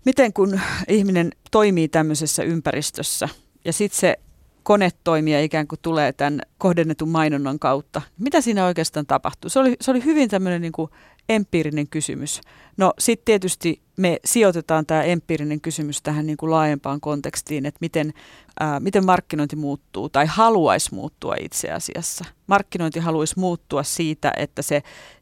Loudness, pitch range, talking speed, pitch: -21 LUFS, 150-185 Hz, 145 wpm, 160 Hz